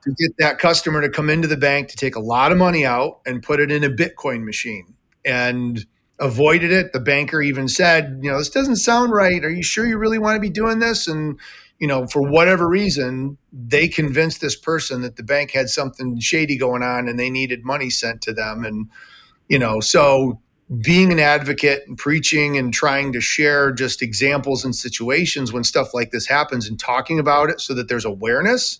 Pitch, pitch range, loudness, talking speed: 140 Hz, 125-160 Hz, -18 LUFS, 210 wpm